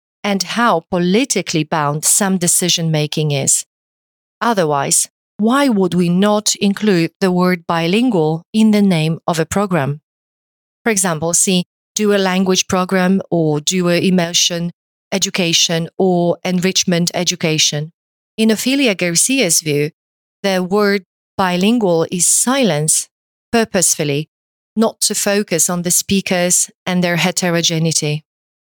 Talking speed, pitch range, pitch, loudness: 120 wpm, 165-200 Hz, 180 Hz, -15 LUFS